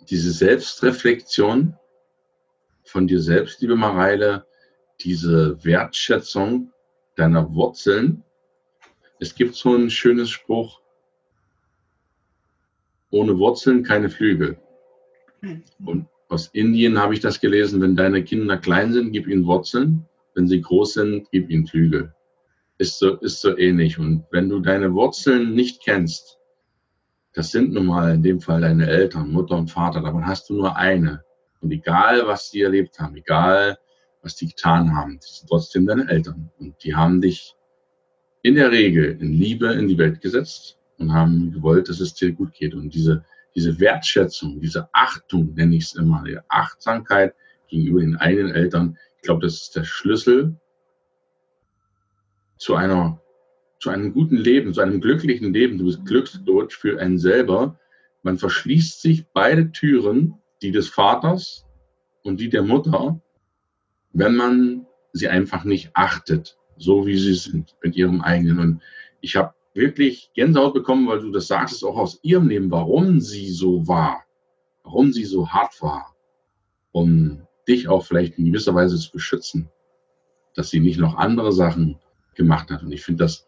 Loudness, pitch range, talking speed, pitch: -19 LUFS, 80-120 Hz, 155 wpm, 95 Hz